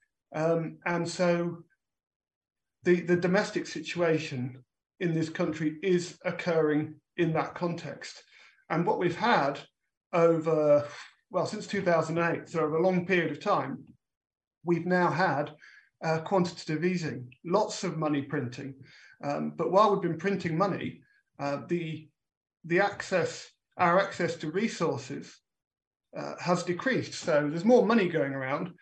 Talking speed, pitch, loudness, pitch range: 135 wpm, 170 Hz, -29 LUFS, 155-180 Hz